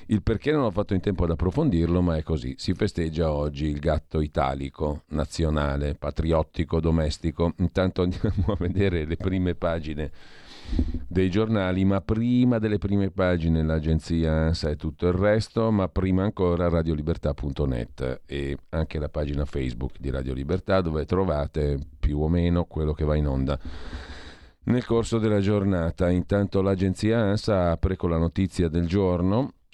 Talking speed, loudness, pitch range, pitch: 155 wpm, -25 LUFS, 75-95 Hz, 85 Hz